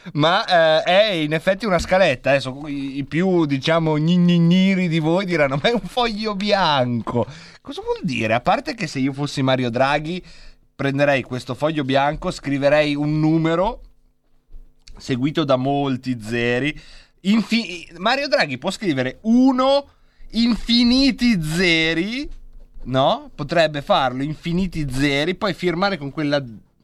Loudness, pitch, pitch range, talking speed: -19 LUFS, 160 Hz, 140-195 Hz, 130 wpm